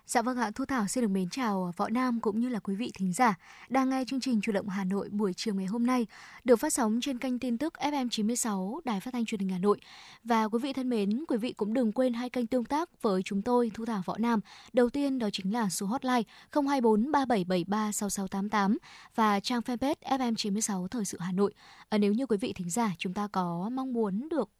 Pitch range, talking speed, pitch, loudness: 205-255 Hz, 230 wpm, 230 Hz, -30 LUFS